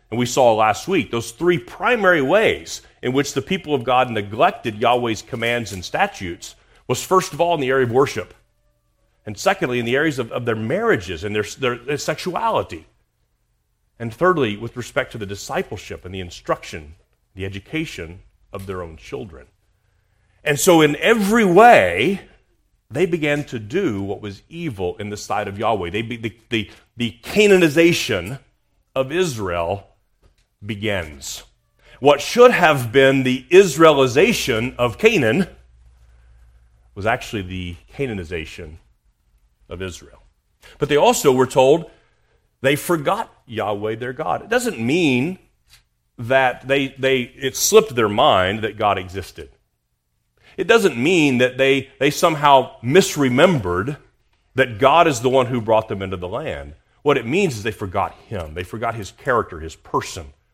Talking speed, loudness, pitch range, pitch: 155 wpm, -18 LUFS, 100-140 Hz, 120 Hz